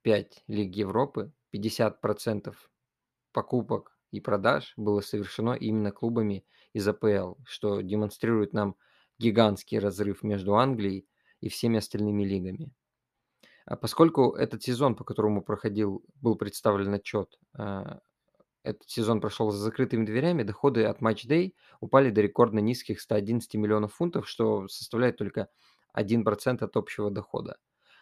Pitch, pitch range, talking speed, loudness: 110 Hz, 105-120 Hz, 125 wpm, -28 LUFS